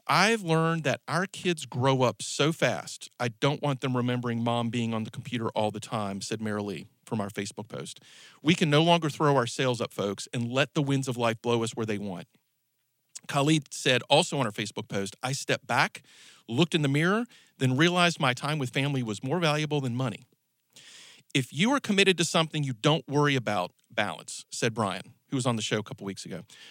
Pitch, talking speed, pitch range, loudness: 135 Hz, 215 wpm, 115-150 Hz, -27 LUFS